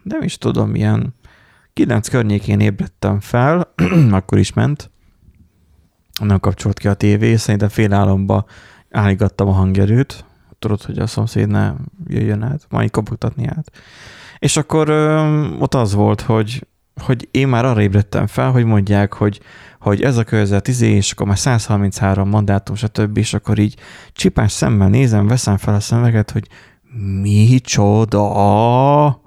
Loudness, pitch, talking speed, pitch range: -15 LUFS, 105 Hz, 145 wpm, 100-125 Hz